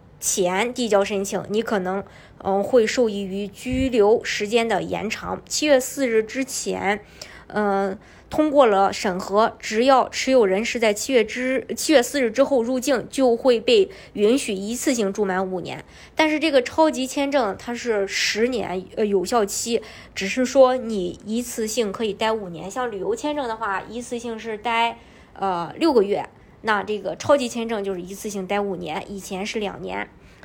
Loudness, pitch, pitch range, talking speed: -22 LUFS, 225 Hz, 200-255 Hz, 250 characters per minute